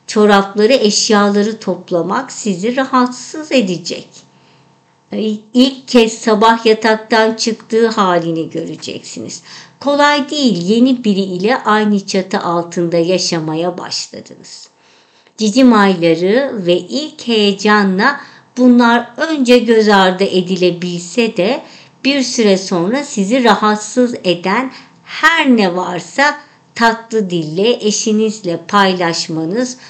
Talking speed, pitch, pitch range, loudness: 95 wpm, 215 Hz, 185-245 Hz, -13 LUFS